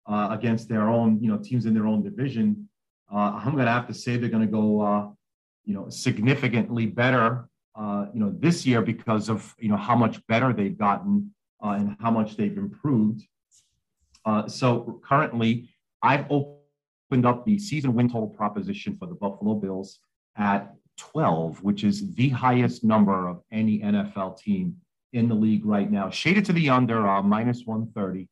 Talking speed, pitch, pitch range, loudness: 180 wpm, 115 Hz, 105-130 Hz, -25 LUFS